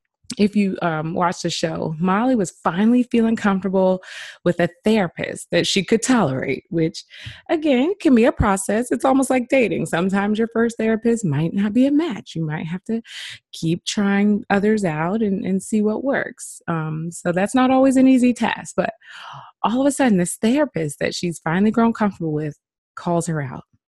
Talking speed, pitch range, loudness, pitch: 185 wpm, 175-230 Hz, -20 LUFS, 200 Hz